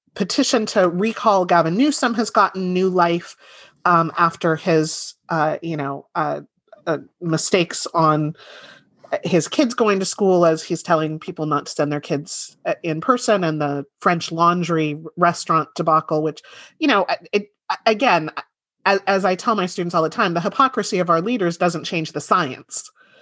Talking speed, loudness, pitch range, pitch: 165 wpm, -20 LUFS, 160-205 Hz, 175 Hz